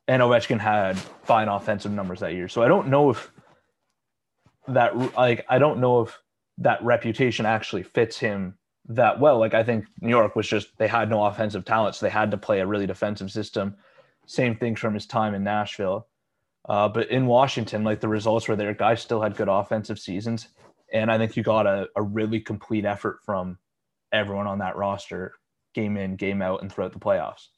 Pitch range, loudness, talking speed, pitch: 100-115 Hz, -24 LUFS, 200 wpm, 110 Hz